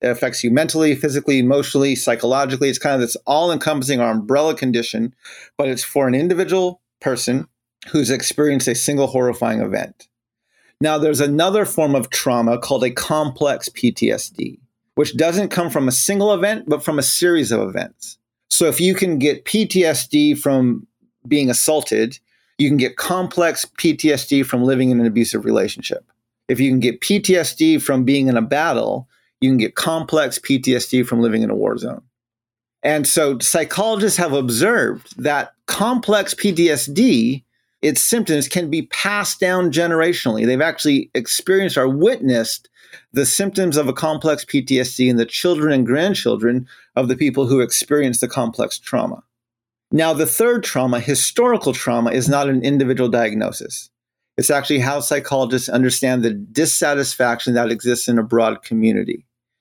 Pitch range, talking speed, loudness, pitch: 125-160 Hz, 155 wpm, -17 LUFS, 140 Hz